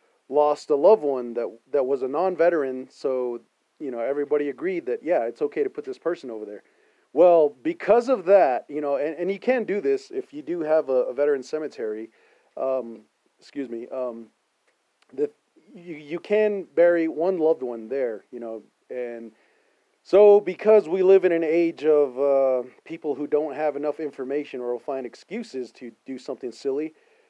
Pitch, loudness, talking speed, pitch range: 155 Hz, -23 LUFS, 180 wpm, 130-215 Hz